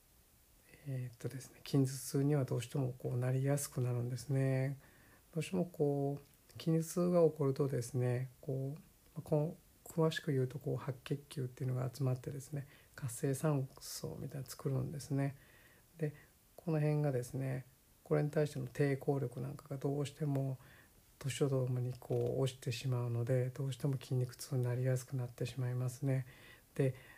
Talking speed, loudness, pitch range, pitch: 350 characters per minute, -38 LUFS, 125-145 Hz, 135 Hz